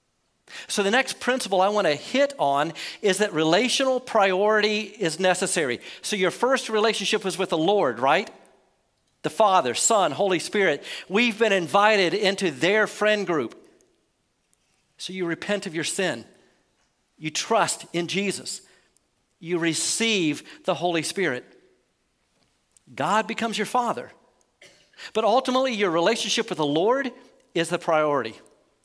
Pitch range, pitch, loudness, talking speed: 170-220 Hz, 200 Hz, -23 LUFS, 135 wpm